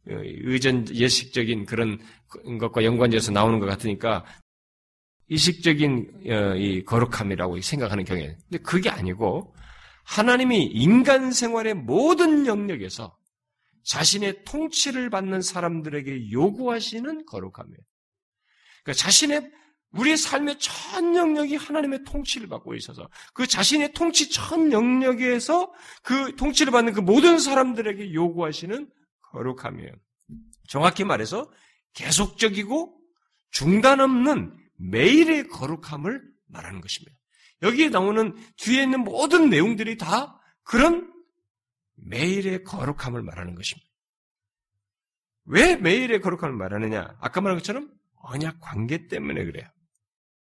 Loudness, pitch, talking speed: -22 LUFS, 190 Hz, 285 characters per minute